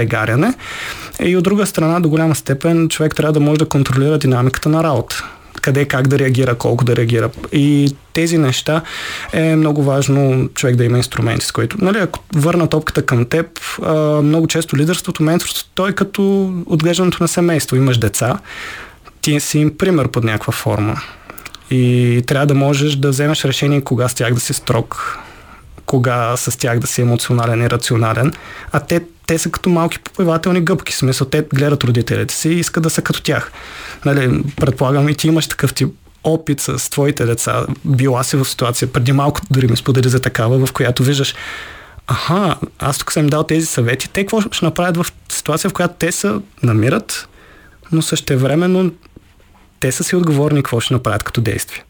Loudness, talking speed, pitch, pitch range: -15 LUFS, 180 wpm, 145 Hz, 130-160 Hz